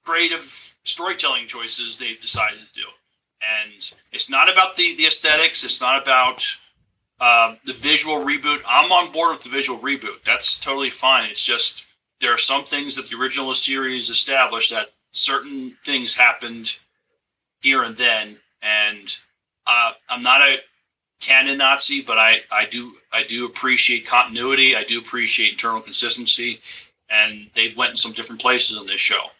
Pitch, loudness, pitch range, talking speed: 130 Hz, -16 LUFS, 115-145 Hz, 160 wpm